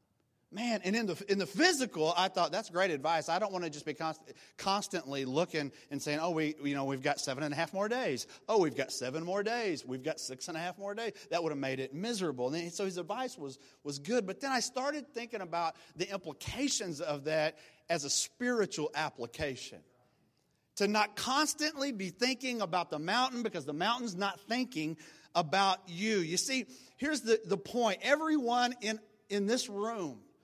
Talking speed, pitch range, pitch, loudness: 205 wpm, 155-225 Hz, 185 Hz, -34 LUFS